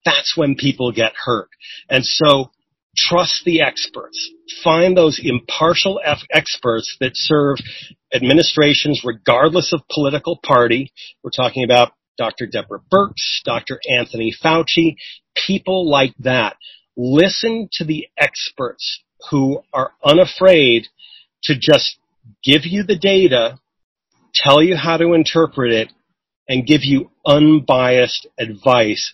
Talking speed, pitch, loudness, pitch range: 115 wpm, 150 Hz, -15 LUFS, 130-170 Hz